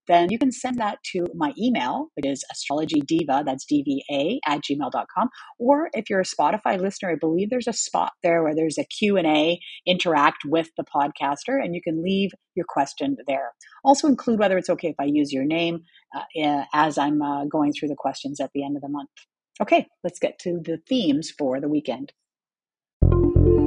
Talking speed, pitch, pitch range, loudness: 190 wpm, 175 Hz, 150-255 Hz, -23 LUFS